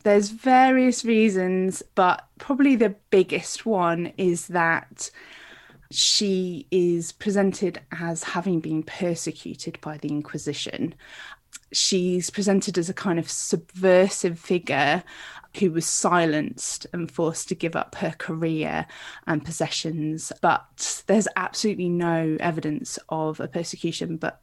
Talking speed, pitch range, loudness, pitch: 120 wpm, 165-195 Hz, -24 LUFS, 175 Hz